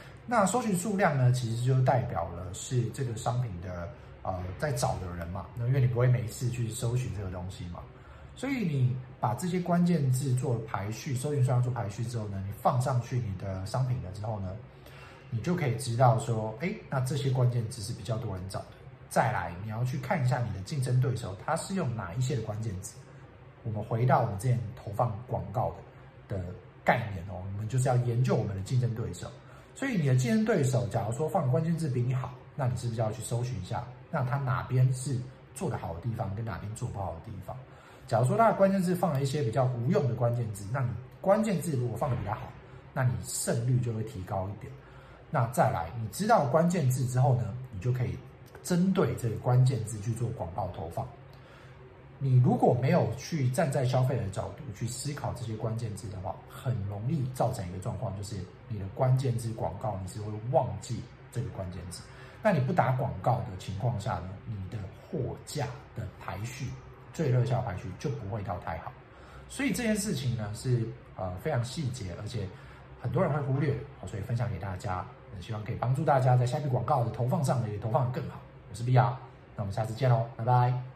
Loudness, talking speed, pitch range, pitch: -31 LUFS, 310 characters per minute, 110-130 Hz, 125 Hz